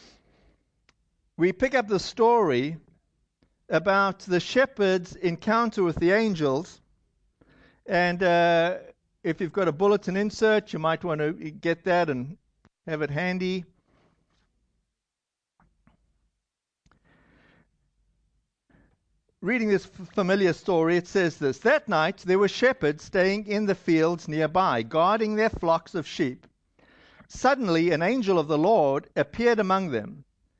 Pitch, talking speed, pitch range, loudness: 180 Hz, 120 wpm, 165-205 Hz, -25 LUFS